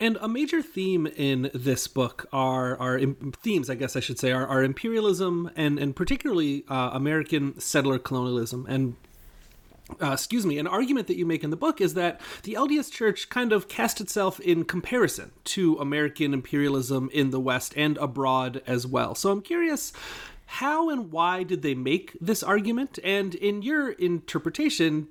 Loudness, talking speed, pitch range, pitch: -26 LUFS, 175 wpm, 135-205 Hz, 155 Hz